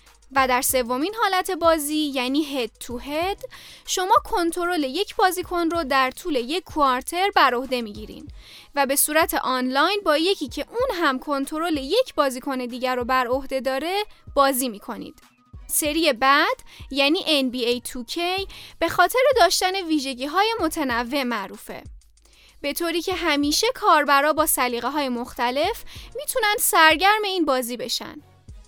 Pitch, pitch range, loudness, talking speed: 295 Hz, 260-355 Hz, -21 LUFS, 140 wpm